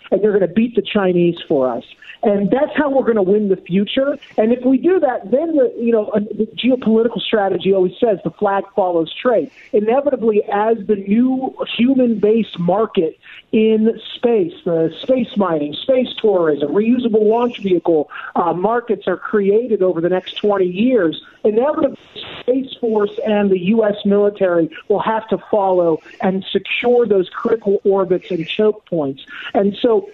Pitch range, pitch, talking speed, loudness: 190-235 Hz, 210 Hz, 160 wpm, -17 LUFS